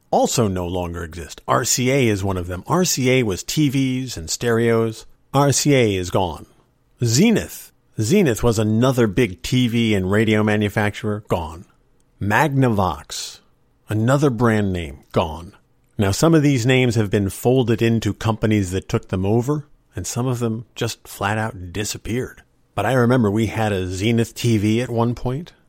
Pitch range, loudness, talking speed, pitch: 100-130 Hz, -19 LUFS, 150 wpm, 115 Hz